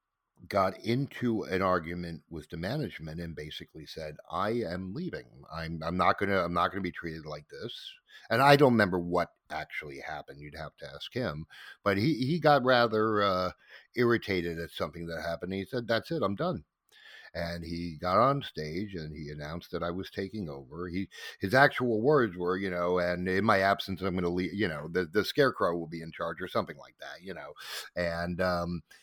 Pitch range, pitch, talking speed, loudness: 85-105 Hz, 90 Hz, 200 wpm, -30 LUFS